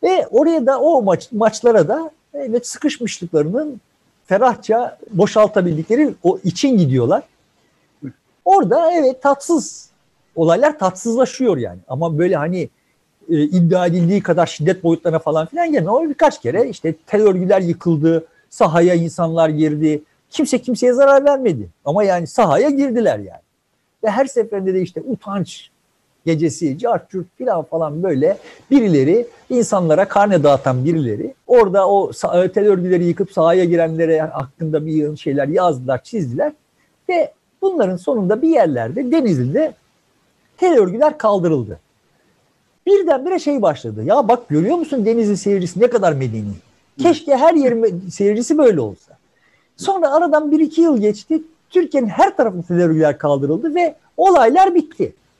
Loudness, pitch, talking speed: -16 LUFS, 200 Hz, 135 wpm